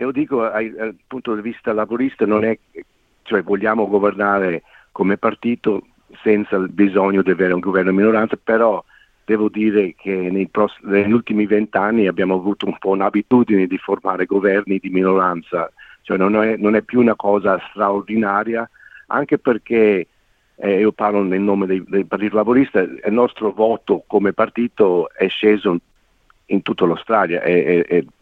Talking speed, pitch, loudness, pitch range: 155 wpm, 105 Hz, -18 LUFS, 95-110 Hz